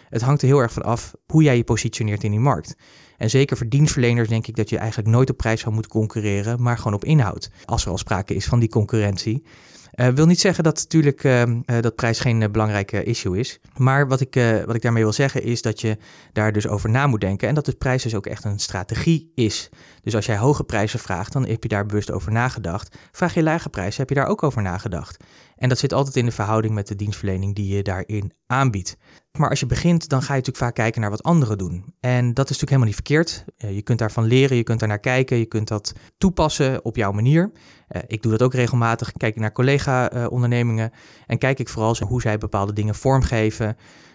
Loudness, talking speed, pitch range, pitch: -21 LUFS, 240 wpm, 105-130 Hz, 115 Hz